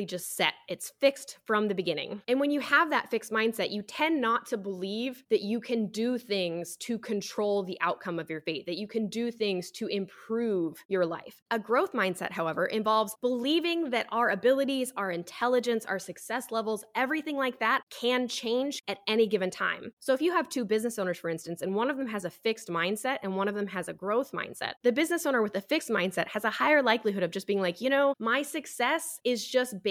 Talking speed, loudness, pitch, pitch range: 220 wpm, -29 LUFS, 225 Hz, 195-250 Hz